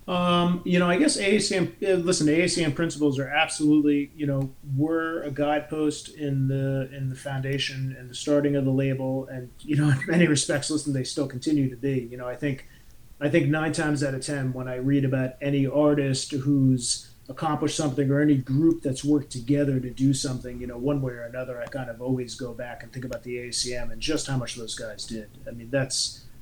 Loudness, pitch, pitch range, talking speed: -25 LUFS, 140 Hz, 130-150 Hz, 220 wpm